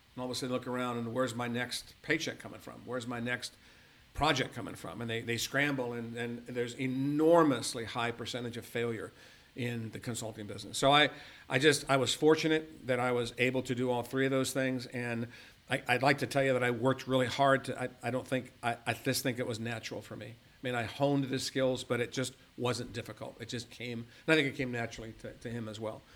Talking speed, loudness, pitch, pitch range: 240 wpm, -33 LUFS, 125 Hz, 120-130 Hz